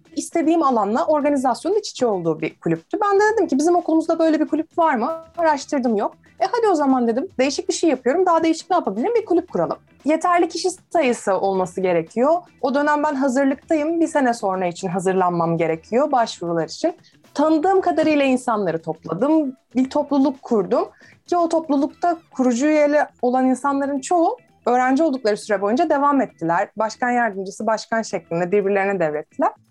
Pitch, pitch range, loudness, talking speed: 275 Hz, 210-325 Hz, -20 LUFS, 165 wpm